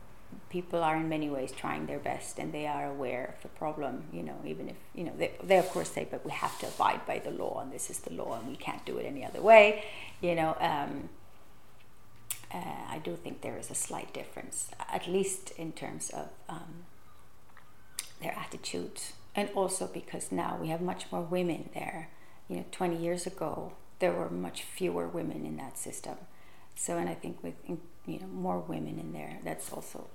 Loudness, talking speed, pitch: -33 LUFS, 205 wpm, 145 Hz